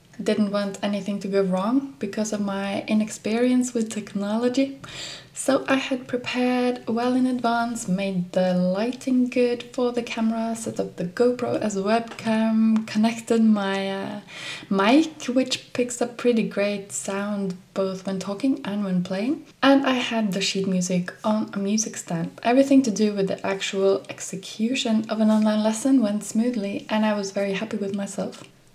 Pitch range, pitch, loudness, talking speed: 200-245 Hz, 220 Hz, -24 LUFS, 165 wpm